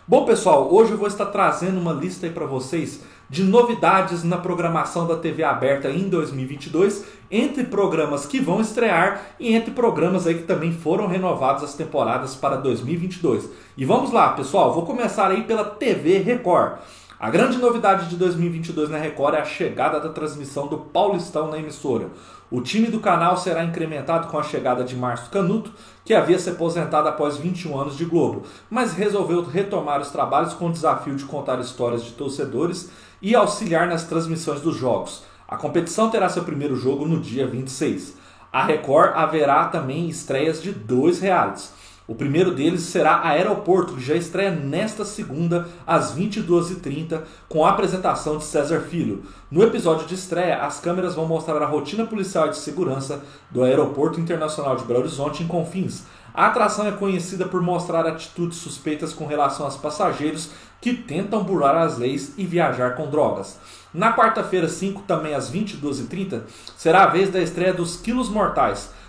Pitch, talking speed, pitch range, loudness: 165 Hz, 170 wpm, 150-190 Hz, -21 LUFS